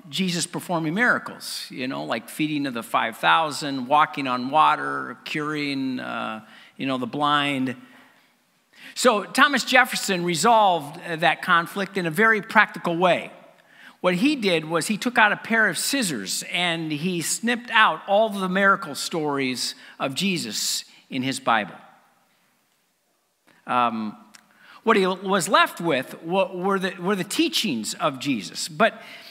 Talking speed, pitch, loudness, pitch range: 140 wpm, 185 Hz, -22 LUFS, 150-220 Hz